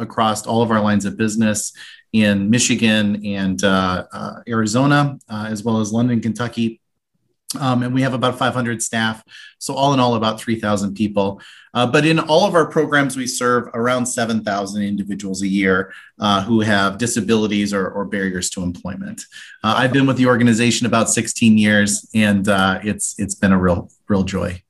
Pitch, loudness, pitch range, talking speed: 110 Hz, -18 LUFS, 100-120 Hz, 180 wpm